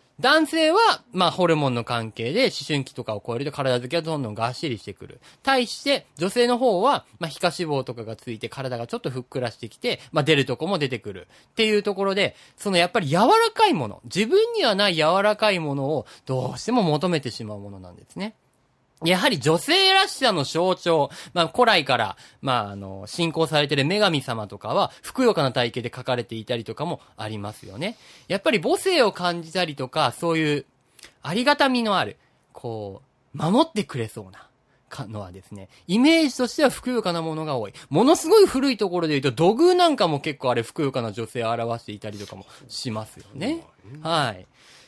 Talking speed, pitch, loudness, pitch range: 395 characters per minute, 150 Hz, -22 LUFS, 120-205 Hz